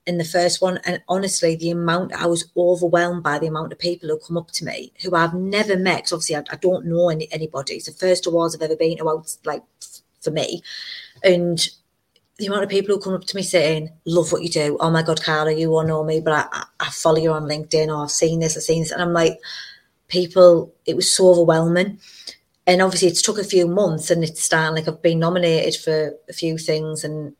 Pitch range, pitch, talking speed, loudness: 160-180 Hz, 170 Hz, 235 wpm, -19 LUFS